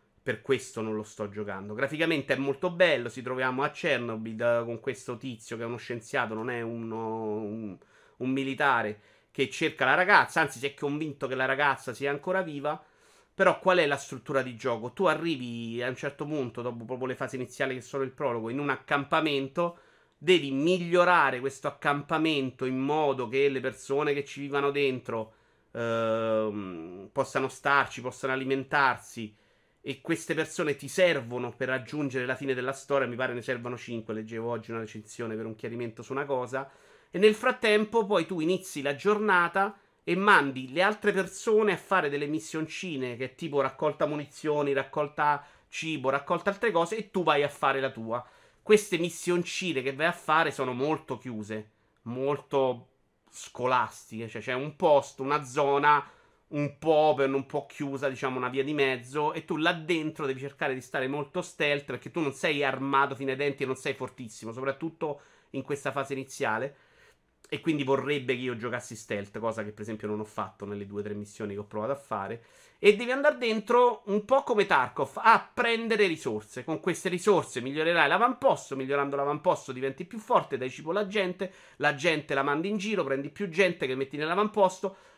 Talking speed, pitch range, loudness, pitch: 185 wpm, 125-160 Hz, -29 LUFS, 140 Hz